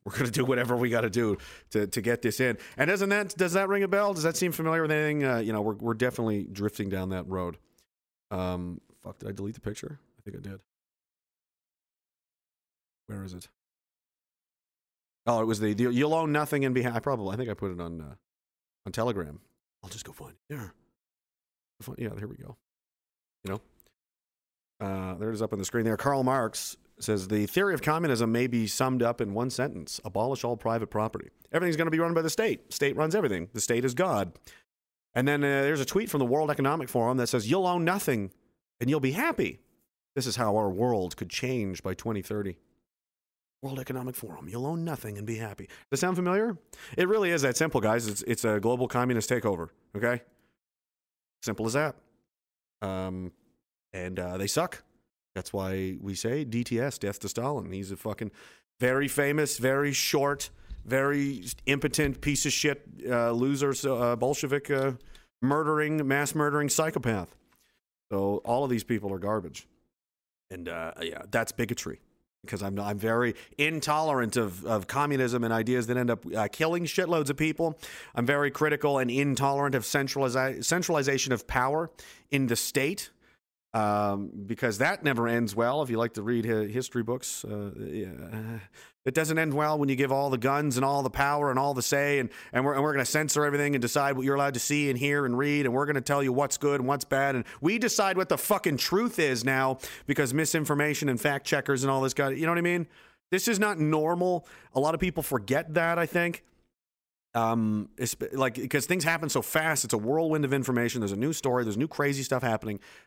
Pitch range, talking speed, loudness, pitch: 110-145 Hz, 205 wpm, -28 LUFS, 130 Hz